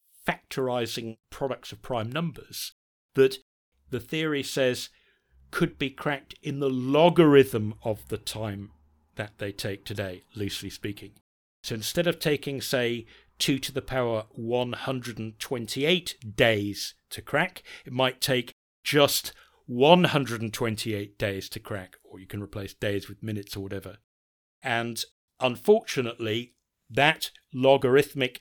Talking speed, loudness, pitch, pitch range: 125 wpm, -27 LUFS, 115 Hz, 105-135 Hz